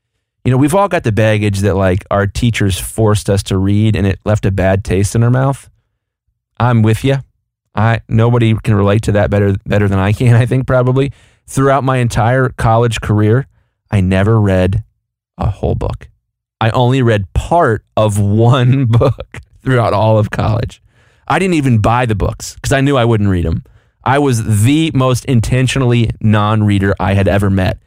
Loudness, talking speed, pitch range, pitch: -13 LUFS, 185 wpm, 100-125 Hz, 110 Hz